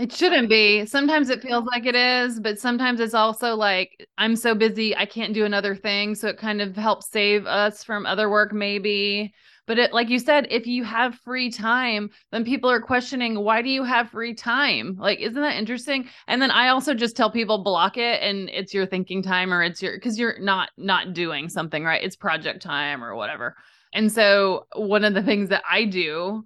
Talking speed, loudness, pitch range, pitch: 215 wpm, -22 LUFS, 200-240 Hz, 215 Hz